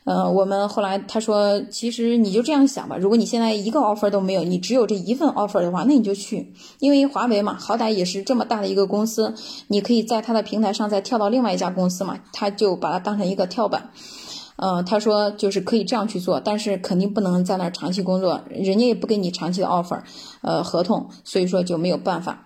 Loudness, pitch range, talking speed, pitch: -21 LUFS, 190-230 Hz, 380 characters per minute, 205 Hz